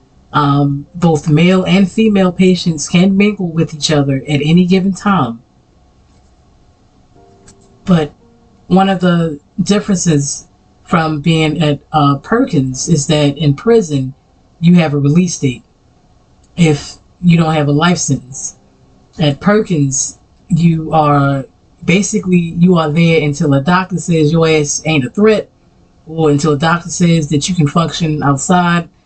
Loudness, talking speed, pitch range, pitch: -12 LUFS, 140 wpm, 145-180 Hz, 160 Hz